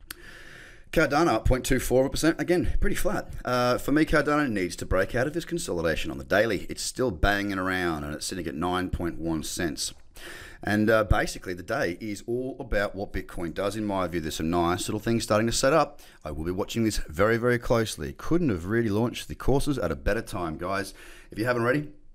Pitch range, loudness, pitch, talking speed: 90-125 Hz, -27 LUFS, 110 Hz, 205 wpm